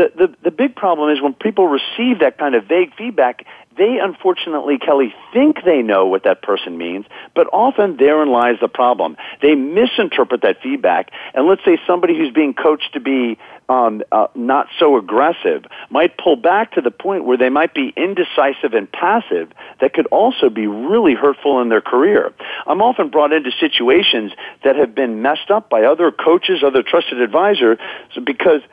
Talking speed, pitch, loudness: 185 wpm, 170 Hz, -15 LUFS